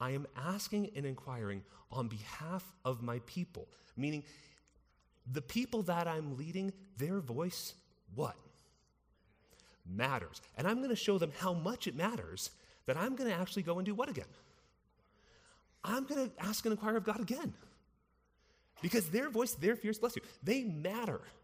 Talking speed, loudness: 160 wpm, -39 LUFS